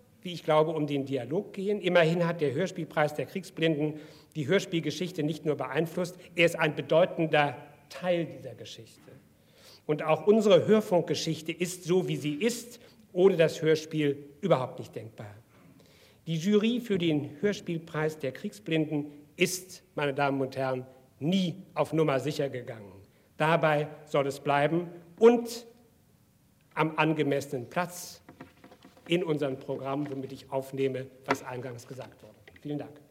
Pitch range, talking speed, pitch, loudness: 140-175 Hz, 140 wpm, 155 Hz, -29 LUFS